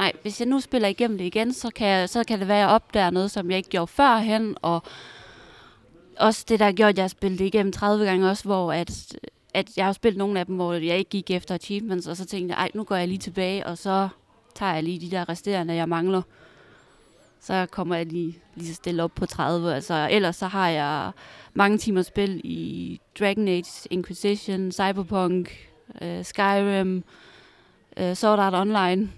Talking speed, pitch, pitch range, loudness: 205 wpm, 190 Hz, 180-205 Hz, -24 LUFS